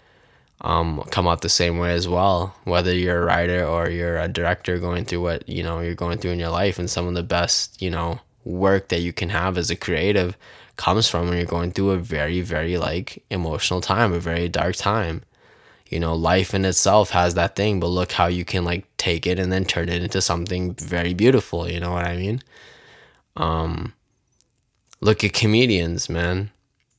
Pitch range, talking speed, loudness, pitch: 85-95 Hz, 205 wpm, -22 LUFS, 90 Hz